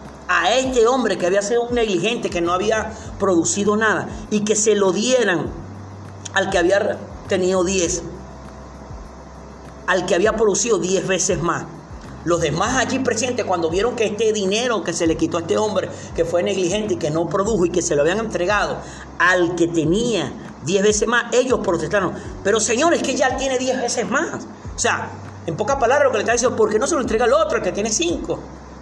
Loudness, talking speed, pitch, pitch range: -19 LUFS, 205 wpm, 195 Hz, 170-225 Hz